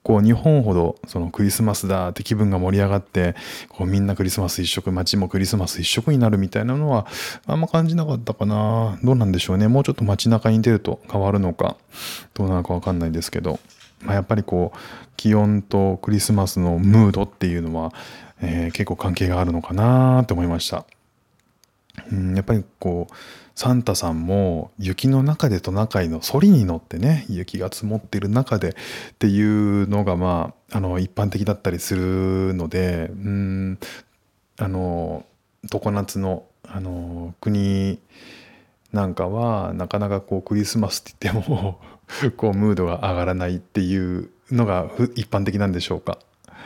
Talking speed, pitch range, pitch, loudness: 340 characters per minute, 90-110 Hz, 100 Hz, -21 LUFS